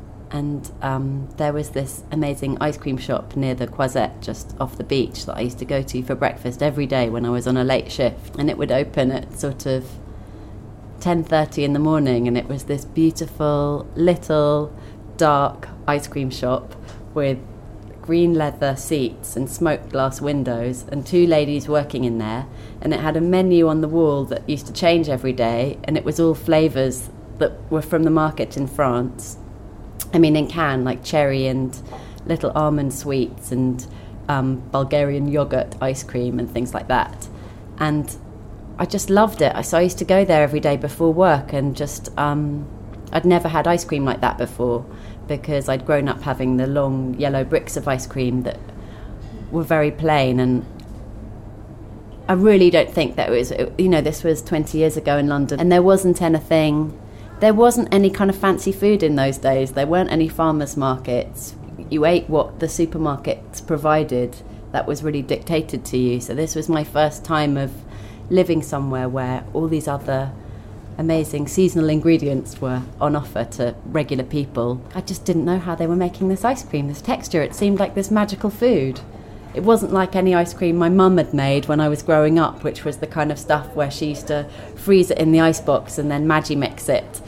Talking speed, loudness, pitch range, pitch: 195 wpm, -20 LUFS, 125-160 Hz, 145 Hz